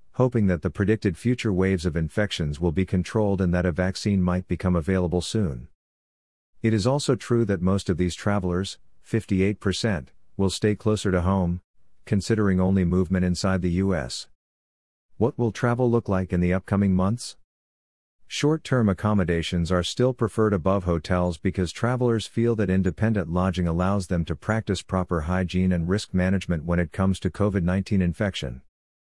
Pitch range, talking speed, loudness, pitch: 90-105 Hz, 165 wpm, -24 LUFS, 95 Hz